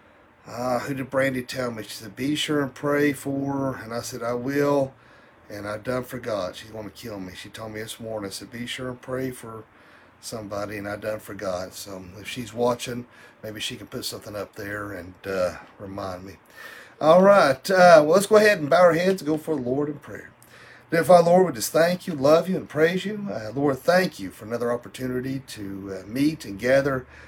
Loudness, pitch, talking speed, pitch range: -23 LUFS, 125 Hz, 225 wpm, 105-145 Hz